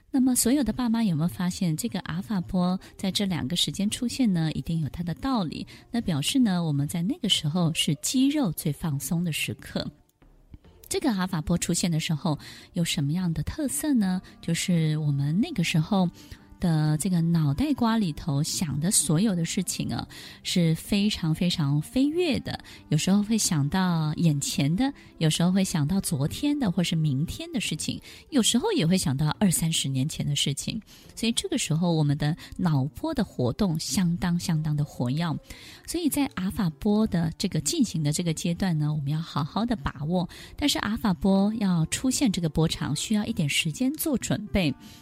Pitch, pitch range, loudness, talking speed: 175 Hz, 155-215 Hz, -26 LUFS, 285 characters per minute